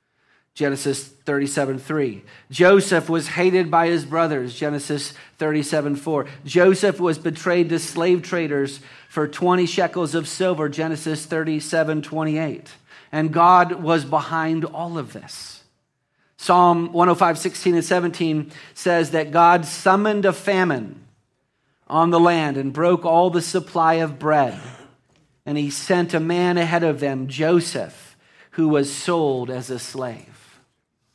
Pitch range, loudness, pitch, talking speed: 145-175 Hz, -20 LUFS, 160 Hz, 135 wpm